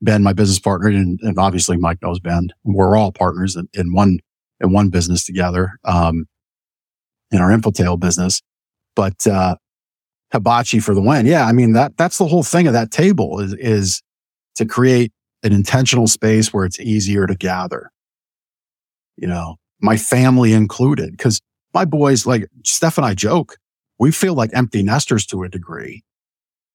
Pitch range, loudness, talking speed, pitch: 90-120 Hz, -16 LUFS, 170 wpm, 100 Hz